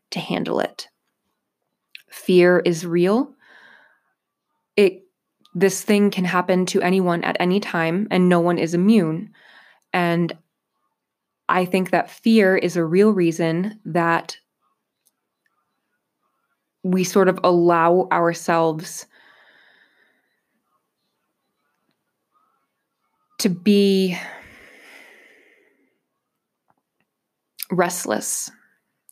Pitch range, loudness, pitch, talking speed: 175-205 Hz, -19 LUFS, 185 Hz, 80 wpm